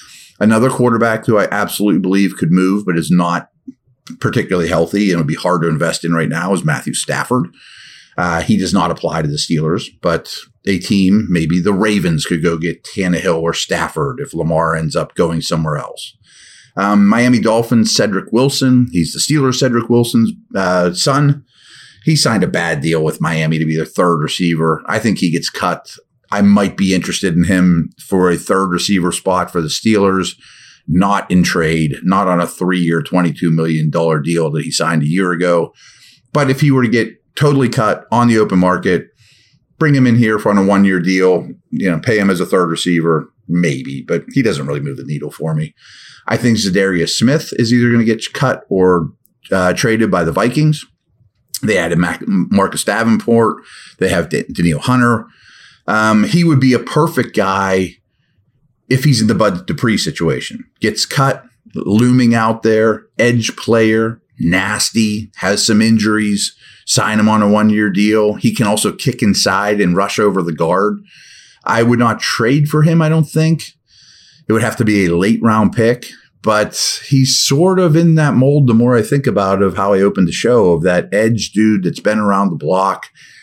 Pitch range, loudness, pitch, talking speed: 90-120 Hz, -14 LUFS, 105 Hz, 190 wpm